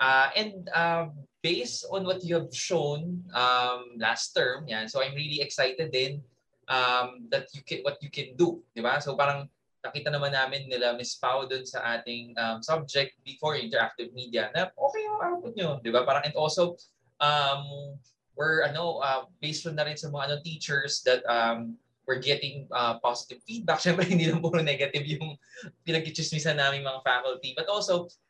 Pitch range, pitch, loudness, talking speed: 130-165 Hz, 140 Hz, -28 LUFS, 180 wpm